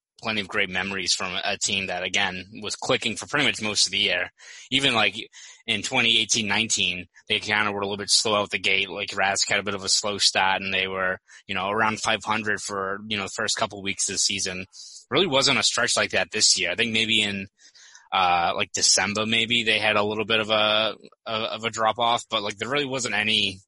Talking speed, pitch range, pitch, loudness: 235 wpm, 95-110 Hz, 105 Hz, -22 LUFS